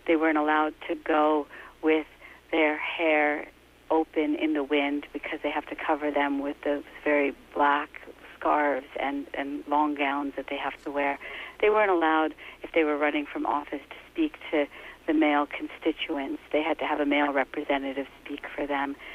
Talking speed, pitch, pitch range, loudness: 180 wpm, 150 Hz, 145-155 Hz, -27 LUFS